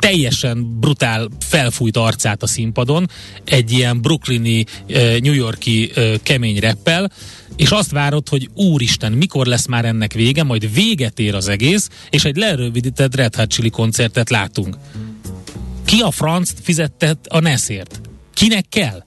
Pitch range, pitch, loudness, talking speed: 110-150 Hz, 125 Hz, -15 LUFS, 140 wpm